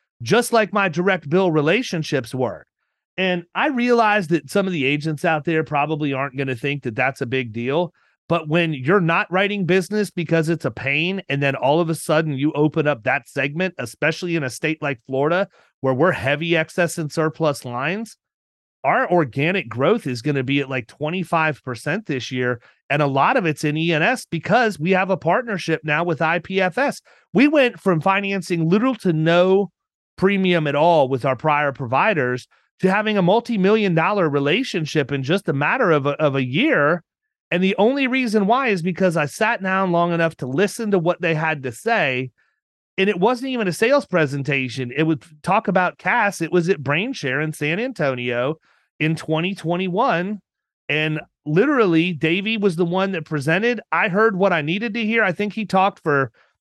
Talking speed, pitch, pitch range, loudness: 190 wpm, 165 Hz, 145-195 Hz, -20 LUFS